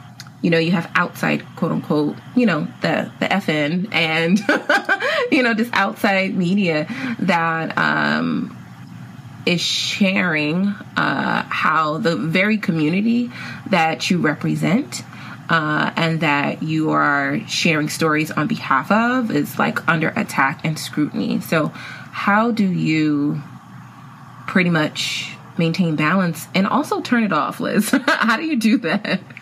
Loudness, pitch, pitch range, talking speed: -19 LUFS, 175 Hz, 155-210 Hz, 135 wpm